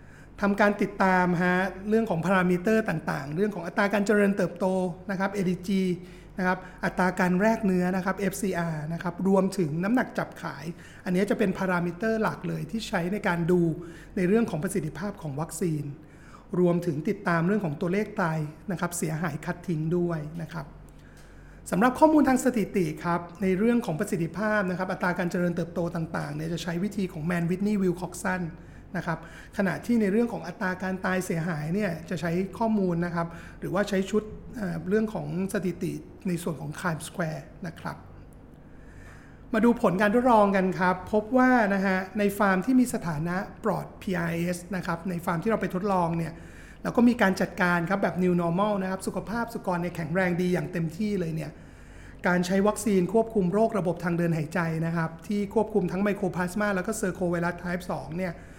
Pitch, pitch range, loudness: 185 Hz, 175-205 Hz, -27 LUFS